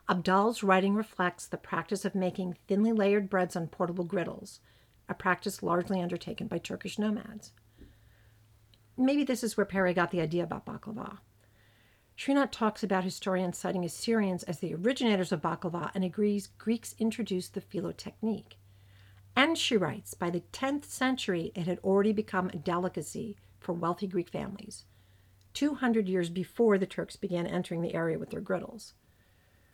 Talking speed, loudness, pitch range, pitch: 155 wpm, -31 LUFS, 170-210 Hz, 185 Hz